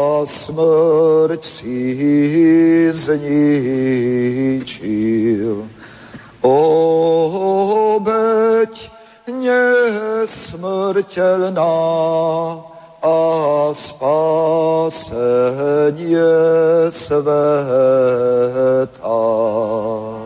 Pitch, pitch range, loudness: 160 Hz, 130-165 Hz, -15 LUFS